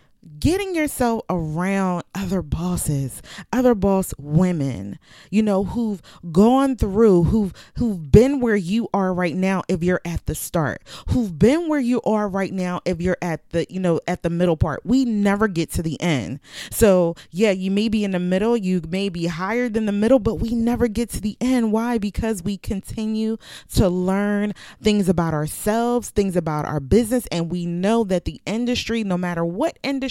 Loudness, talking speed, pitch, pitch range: -21 LUFS, 185 wpm, 195 Hz, 175-225 Hz